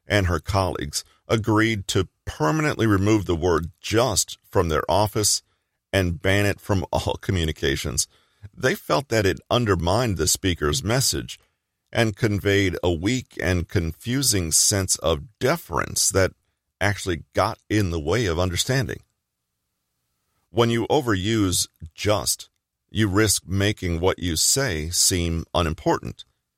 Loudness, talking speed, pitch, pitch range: -22 LUFS, 125 wpm, 95 Hz, 85-105 Hz